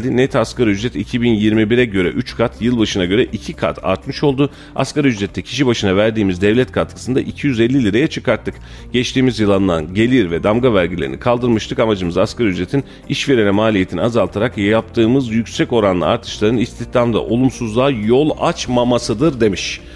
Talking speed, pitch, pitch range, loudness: 140 wpm, 115 Hz, 100-125 Hz, -16 LUFS